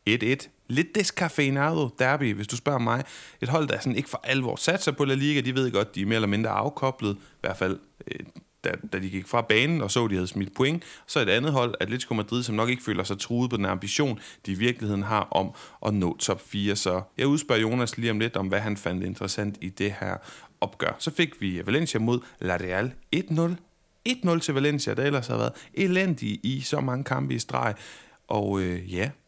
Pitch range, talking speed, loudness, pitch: 100-145 Hz, 225 wpm, -27 LUFS, 120 Hz